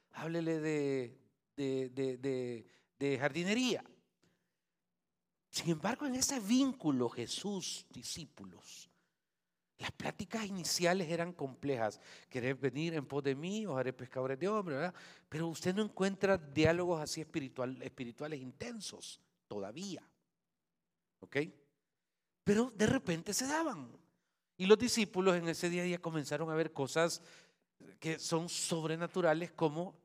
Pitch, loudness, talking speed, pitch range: 165 Hz, -36 LUFS, 125 wpm, 140-190 Hz